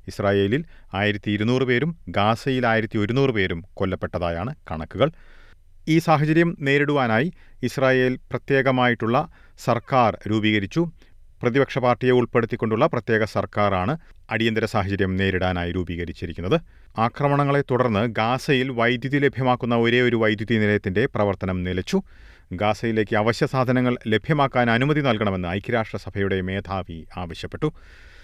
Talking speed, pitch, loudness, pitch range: 100 wpm, 115 Hz, -22 LUFS, 100-130 Hz